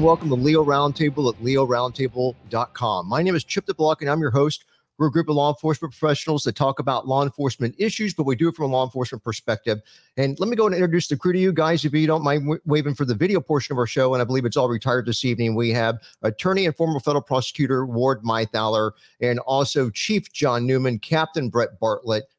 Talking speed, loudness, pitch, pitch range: 230 wpm, -22 LUFS, 140 Hz, 125-155 Hz